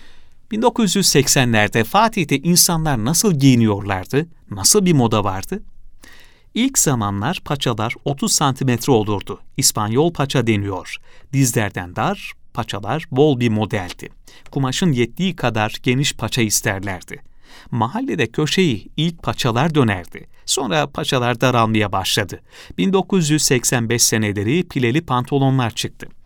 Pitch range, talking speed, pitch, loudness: 110-160 Hz, 100 wpm, 130 Hz, -18 LUFS